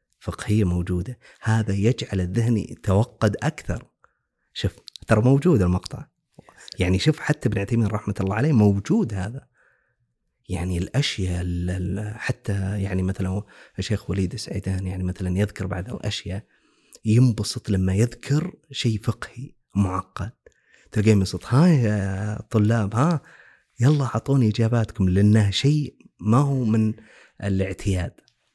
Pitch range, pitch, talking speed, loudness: 95-120 Hz, 105 Hz, 115 wpm, -23 LUFS